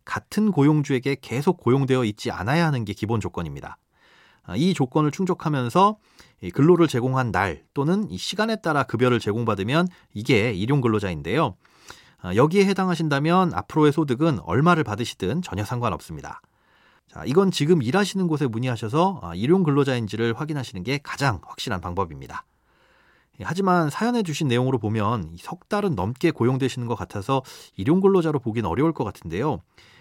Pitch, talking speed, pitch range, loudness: 140 Hz, 365 characters per minute, 115-170 Hz, -23 LUFS